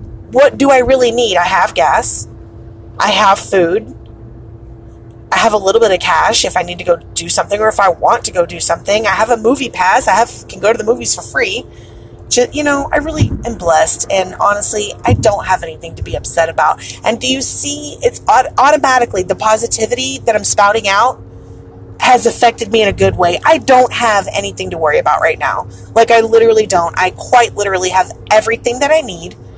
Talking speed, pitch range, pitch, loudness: 210 wpm, 180-250 Hz, 220 Hz, -12 LUFS